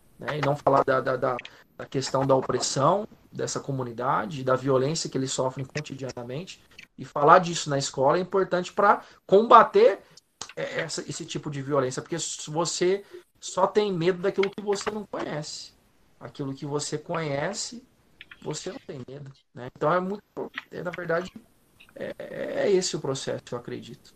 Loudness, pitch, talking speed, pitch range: -26 LUFS, 165 Hz, 160 wpm, 135-190 Hz